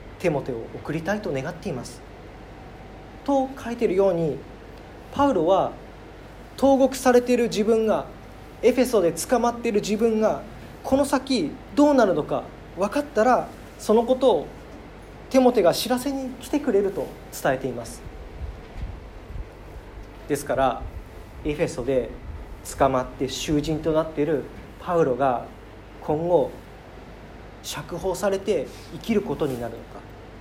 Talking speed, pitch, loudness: 260 characters per minute, 210 Hz, -23 LUFS